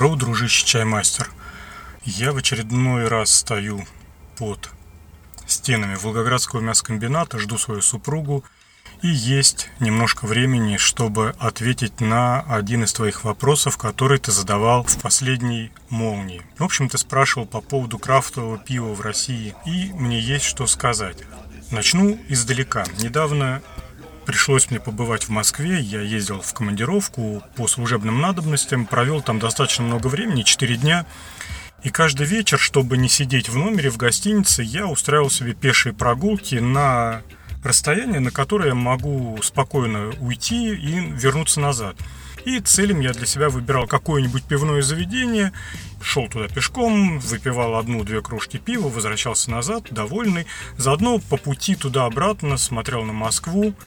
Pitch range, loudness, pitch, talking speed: 110-145 Hz, -19 LUFS, 125 Hz, 135 wpm